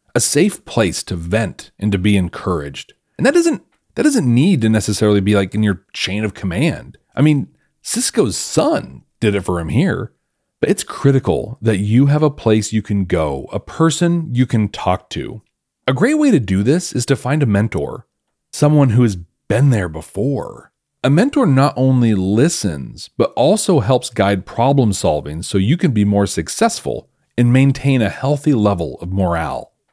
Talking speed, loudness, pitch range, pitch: 180 wpm, -16 LUFS, 100-140 Hz, 110 Hz